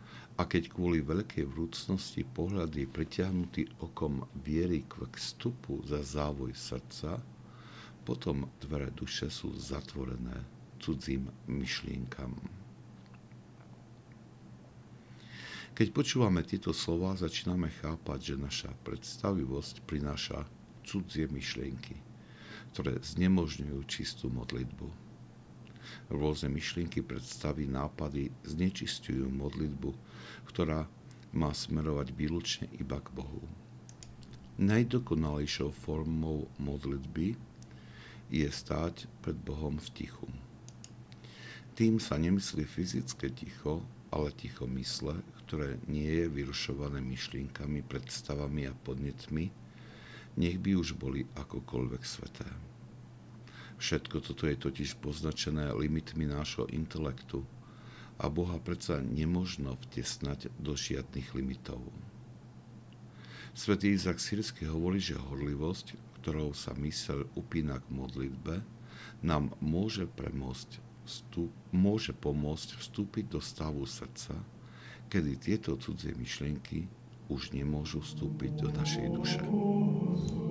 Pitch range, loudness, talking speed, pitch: 65-90 Hz, -36 LUFS, 95 wpm, 75 Hz